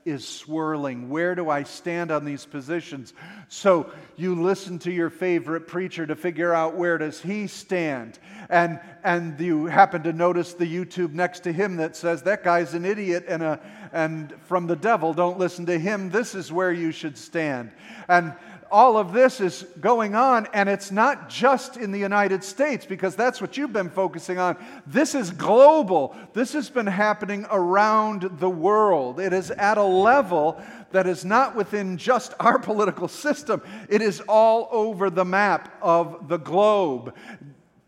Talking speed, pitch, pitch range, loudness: 175 wpm, 185 Hz, 170-210 Hz, -23 LUFS